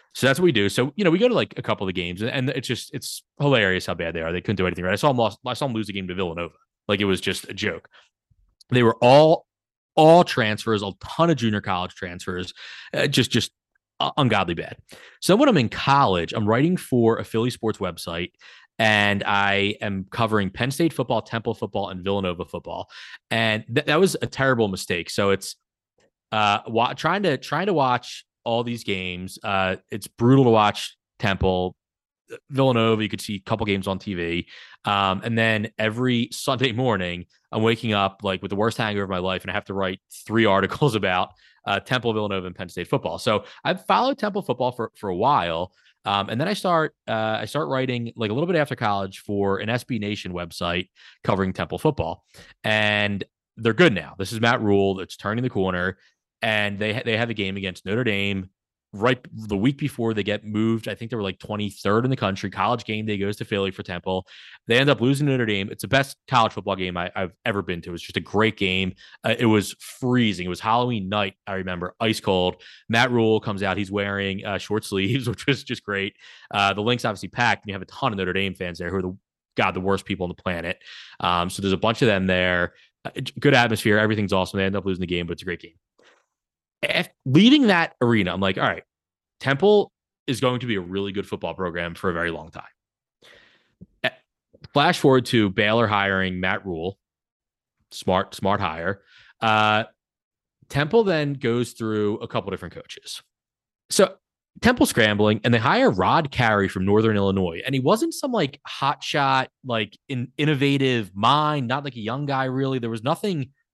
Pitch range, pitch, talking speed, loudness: 95-125 Hz, 105 Hz, 215 wpm, -23 LUFS